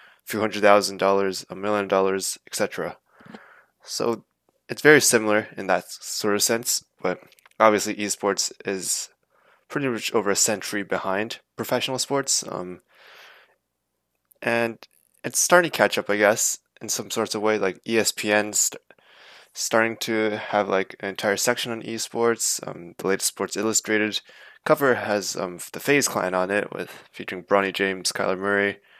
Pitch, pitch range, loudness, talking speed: 105 Hz, 95-115 Hz, -23 LUFS, 155 wpm